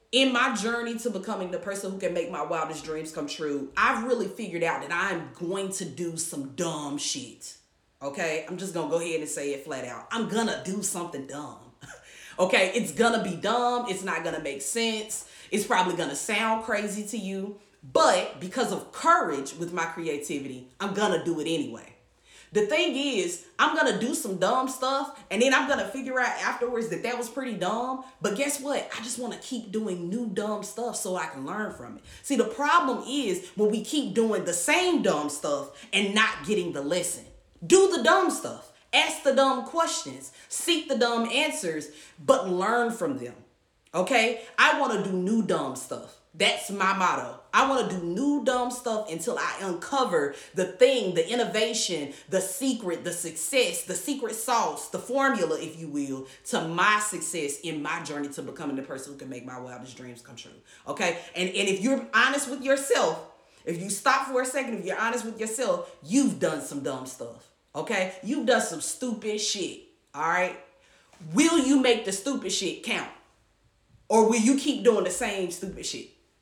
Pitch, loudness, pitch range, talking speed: 210 Hz, -27 LUFS, 170-255 Hz, 190 wpm